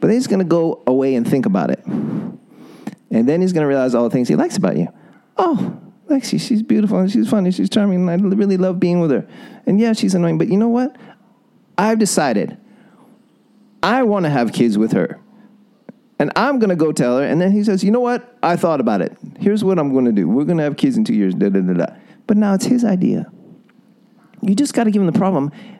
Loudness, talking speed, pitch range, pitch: -17 LUFS, 235 wpm, 175-230 Hz, 210 Hz